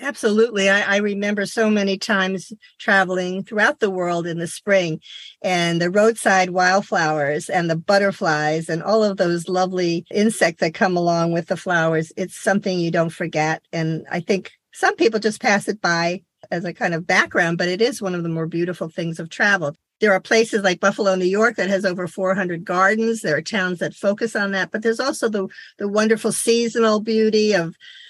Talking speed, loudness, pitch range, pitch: 195 wpm, -20 LUFS, 175-210 Hz, 190 Hz